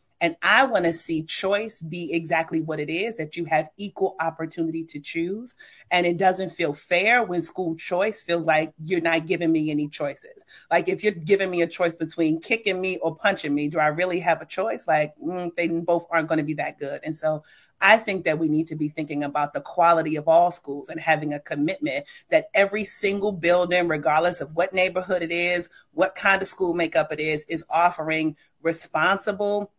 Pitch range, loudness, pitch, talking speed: 160-190 Hz, -23 LUFS, 170 Hz, 205 wpm